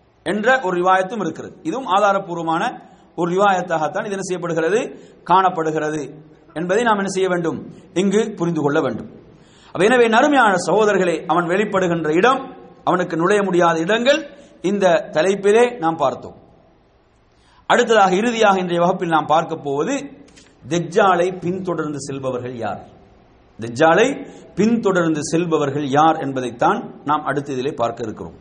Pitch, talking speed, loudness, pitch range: 175 Hz, 115 wpm, -18 LUFS, 155-200 Hz